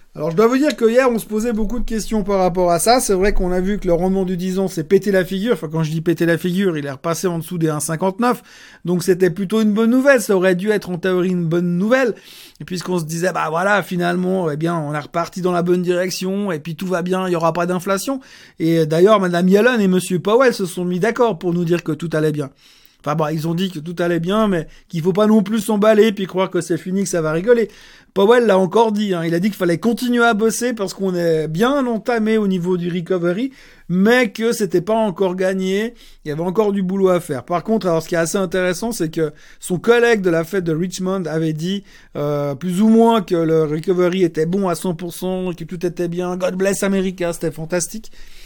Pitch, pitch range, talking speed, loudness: 185 Hz, 170-215 Hz, 255 wpm, -18 LUFS